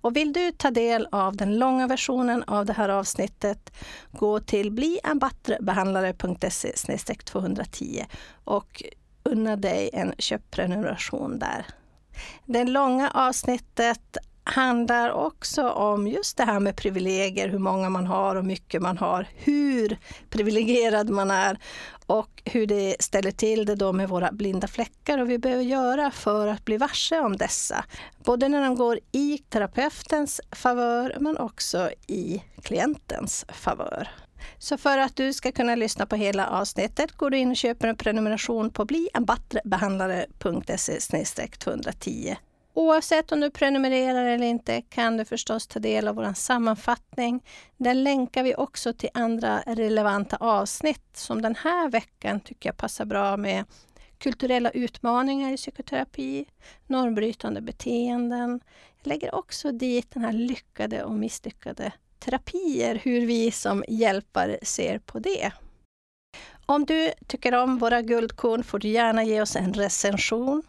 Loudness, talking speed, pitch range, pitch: -26 LUFS, 140 wpm, 205-260 Hz, 235 Hz